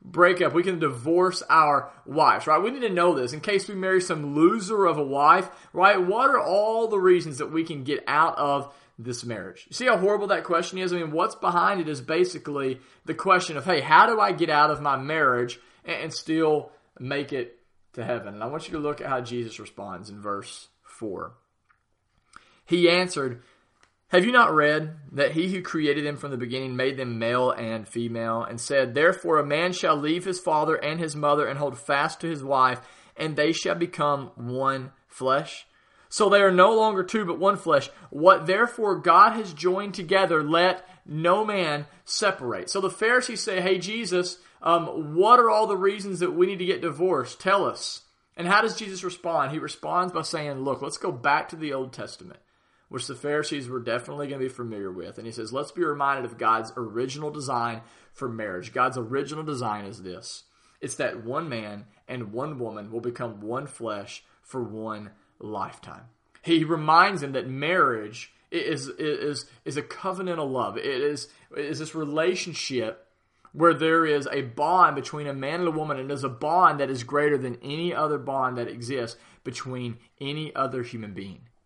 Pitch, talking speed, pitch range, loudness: 150 Hz, 195 wpm, 125-175 Hz, -24 LUFS